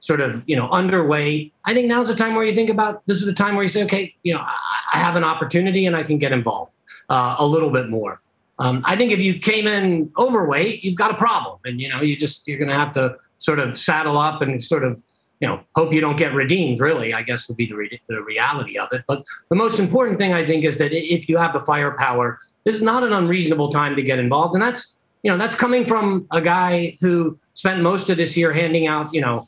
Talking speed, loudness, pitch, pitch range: 260 wpm, -19 LUFS, 165 Hz, 145-200 Hz